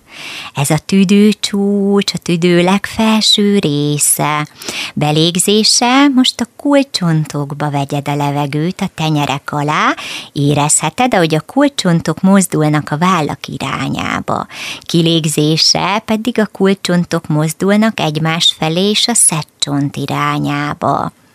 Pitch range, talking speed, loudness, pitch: 150-205 Hz, 100 wpm, -13 LUFS, 170 Hz